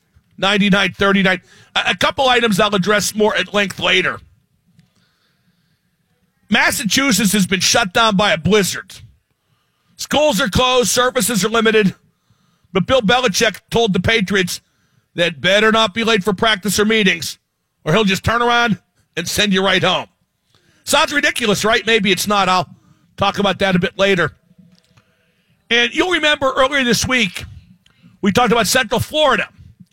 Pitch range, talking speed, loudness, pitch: 185-235 Hz, 150 wpm, -15 LUFS, 205 Hz